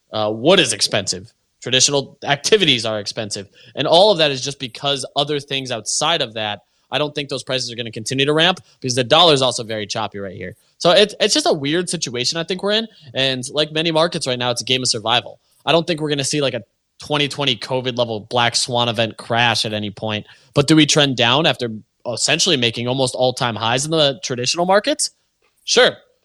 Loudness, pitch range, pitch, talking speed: -17 LUFS, 115-150 Hz, 130 Hz, 225 wpm